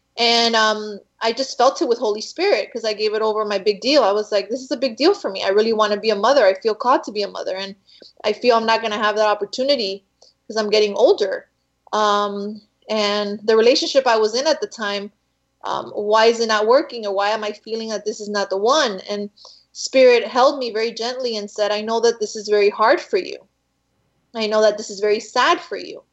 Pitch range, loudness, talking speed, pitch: 210-250 Hz, -19 LUFS, 250 wpm, 220 Hz